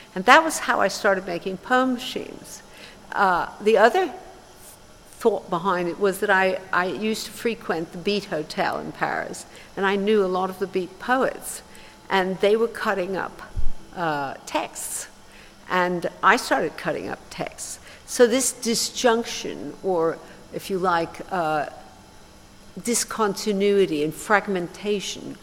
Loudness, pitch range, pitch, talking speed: -23 LUFS, 180-225 Hz, 195 Hz, 140 wpm